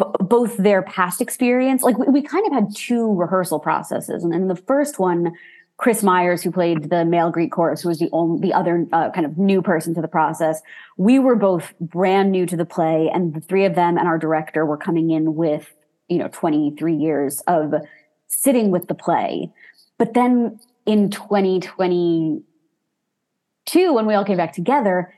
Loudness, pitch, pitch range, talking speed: -19 LUFS, 180 Hz, 165-210 Hz, 195 wpm